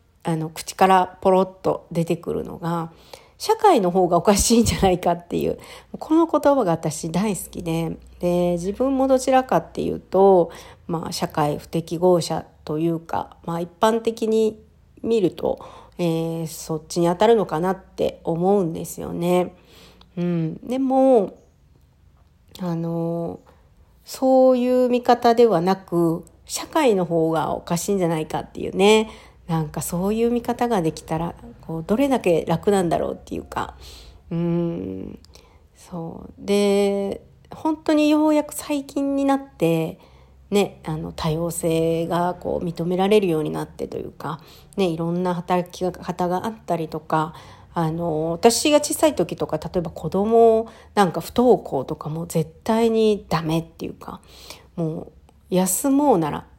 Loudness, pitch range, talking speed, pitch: -21 LUFS, 165-220 Hz, 285 characters per minute, 175 Hz